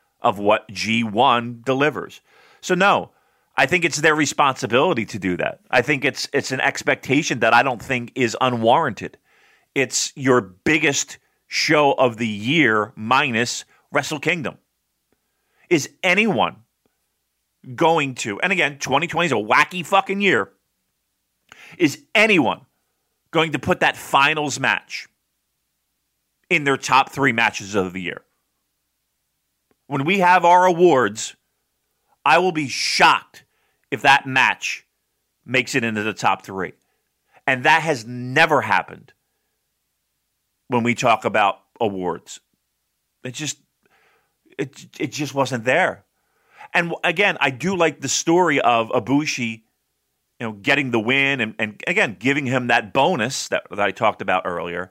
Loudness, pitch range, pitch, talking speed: -19 LUFS, 120-155 Hz, 135 Hz, 140 wpm